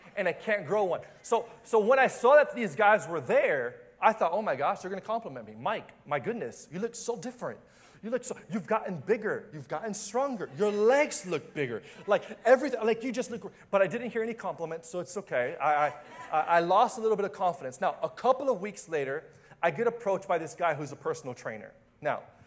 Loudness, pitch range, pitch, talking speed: -29 LUFS, 170-235 Hz, 210 Hz, 230 wpm